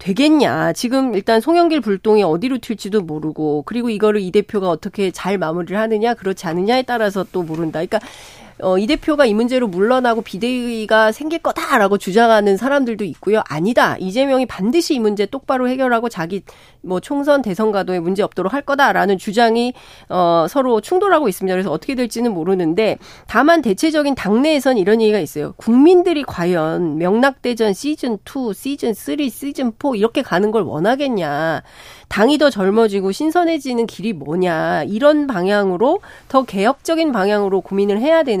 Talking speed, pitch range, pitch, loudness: 380 characters per minute, 190-270 Hz, 220 Hz, -17 LUFS